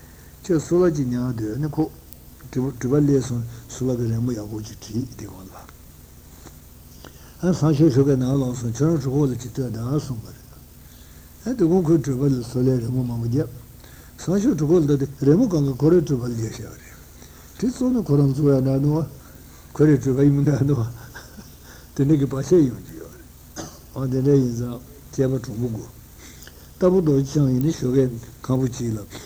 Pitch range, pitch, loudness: 115-145 Hz, 130 Hz, -21 LUFS